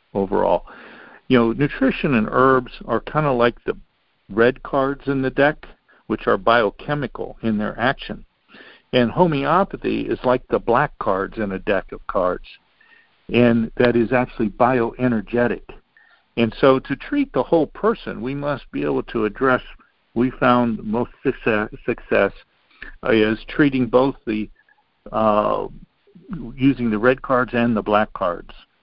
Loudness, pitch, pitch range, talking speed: -20 LUFS, 125 Hz, 115-135 Hz, 145 wpm